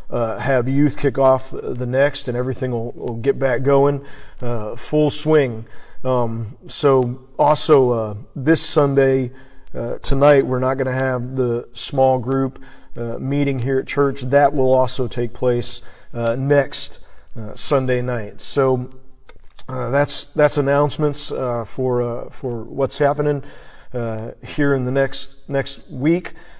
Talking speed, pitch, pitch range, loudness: 150 wpm, 130 Hz, 125-140 Hz, -19 LUFS